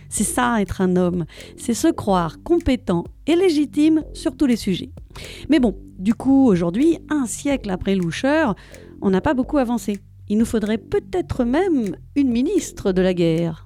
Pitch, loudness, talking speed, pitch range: 235 Hz, -20 LUFS, 170 wpm, 185-300 Hz